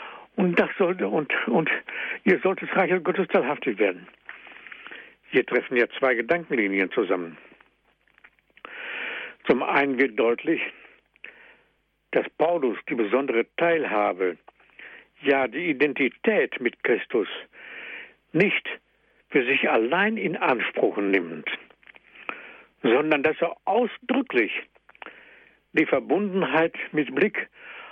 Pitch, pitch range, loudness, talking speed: 170 Hz, 140-230 Hz, -24 LUFS, 100 wpm